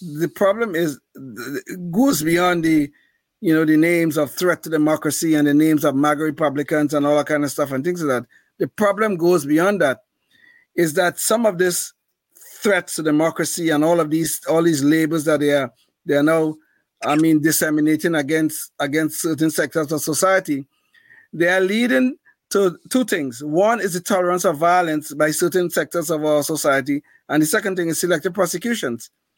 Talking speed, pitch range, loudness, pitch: 185 wpm, 150-180 Hz, -19 LUFS, 160 Hz